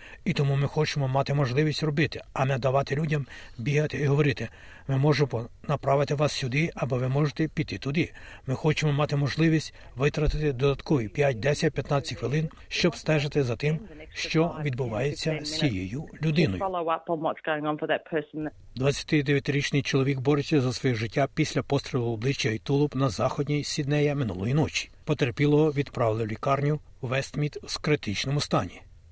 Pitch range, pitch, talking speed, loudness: 135-150 Hz, 145 Hz, 140 wpm, -27 LUFS